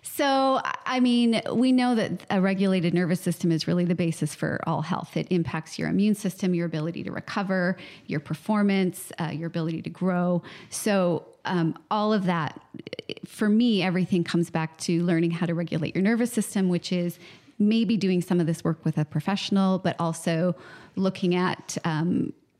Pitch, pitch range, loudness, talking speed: 180 Hz, 170-200 Hz, -26 LUFS, 180 wpm